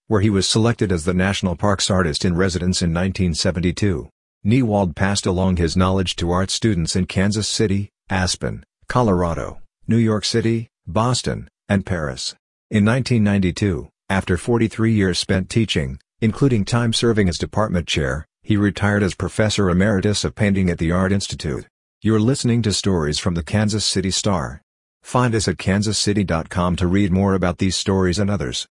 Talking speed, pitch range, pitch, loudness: 155 wpm, 90-110 Hz, 95 Hz, -19 LUFS